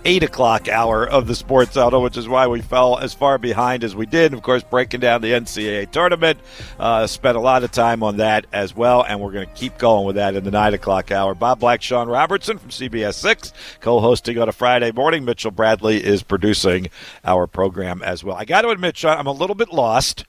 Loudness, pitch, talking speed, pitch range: -18 LUFS, 120 Hz, 230 wpm, 105-130 Hz